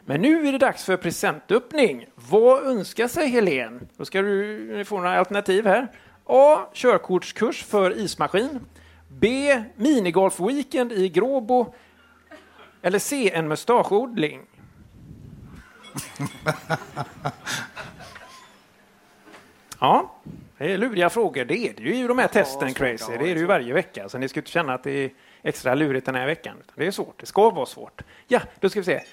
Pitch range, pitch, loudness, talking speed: 155-250 Hz, 195 Hz, -22 LUFS, 150 wpm